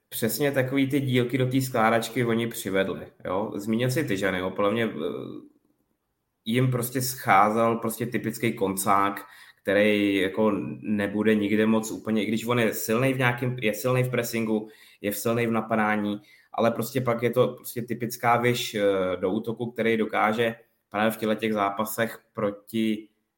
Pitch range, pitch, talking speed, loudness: 105-120 Hz, 115 Hz, 155 wpm, -25 LUFS